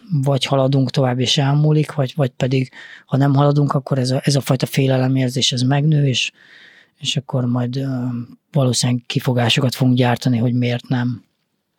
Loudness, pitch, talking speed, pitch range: -18 LUFS, 135 Hz, 160 wpm, 125-140 Hz